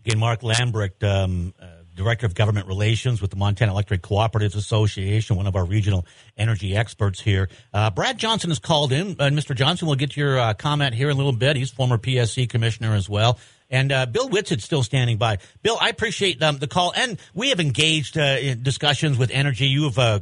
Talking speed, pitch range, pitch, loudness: 220 wpm, 105-145 Hz, 120 Hz, -21 LUFS